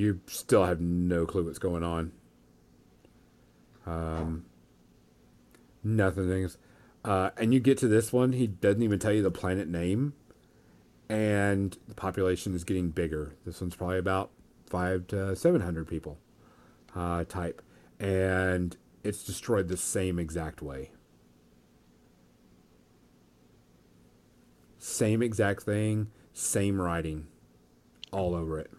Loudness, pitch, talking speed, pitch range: -30 LUFS, 90 Hz, 120 wpm, 75-100 Hz